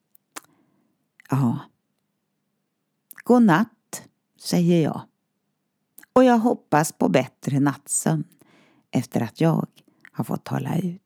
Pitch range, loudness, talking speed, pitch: 165-235 Hz, -22 LUFS, 100 wpm, 200 Hz